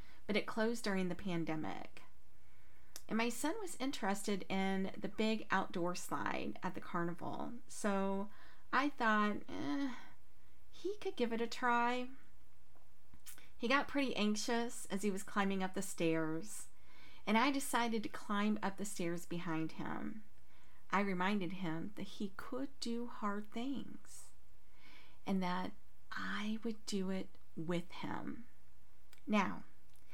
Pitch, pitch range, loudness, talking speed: 210 Hz, 185-240 Hz, -39 LUFS, 135 wpm